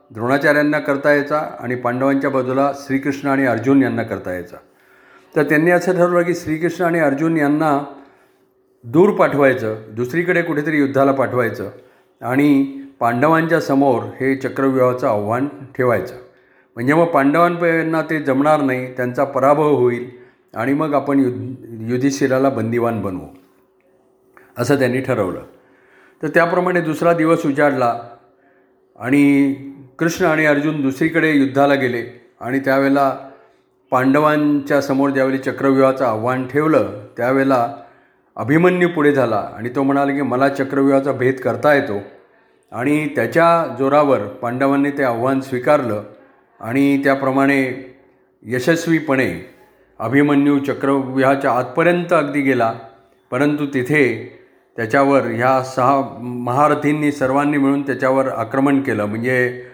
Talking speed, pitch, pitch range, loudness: 115 wpm, 135 Hz, 125-145 Hz, -17 LUFS